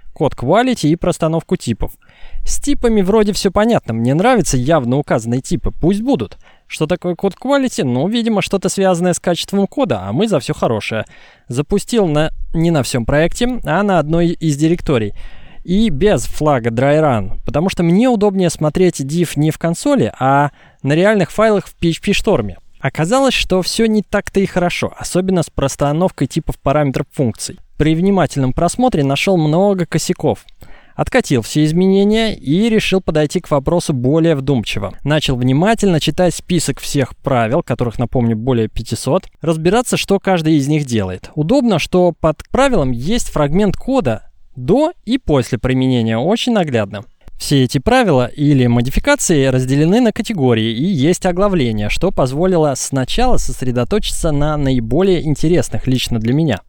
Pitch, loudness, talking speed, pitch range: 165 Hz, -15 LUFS, 150 wpm, 135-195 Hz